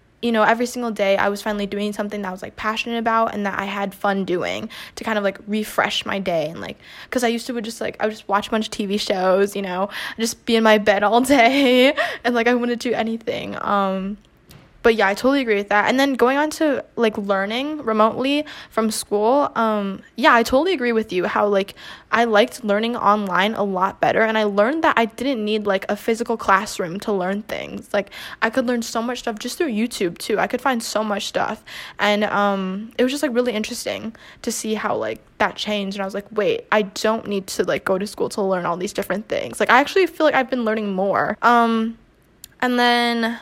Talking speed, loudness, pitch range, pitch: 240 wpm, -20 LUFS, 205-240 Hz, 220 Hz